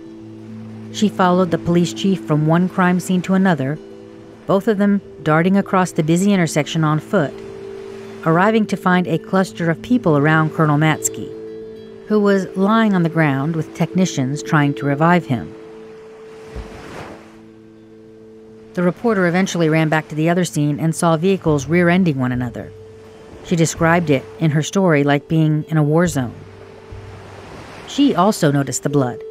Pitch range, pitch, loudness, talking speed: 125-185 Hz, 160 Hz, -17 LUFS, 155 wpm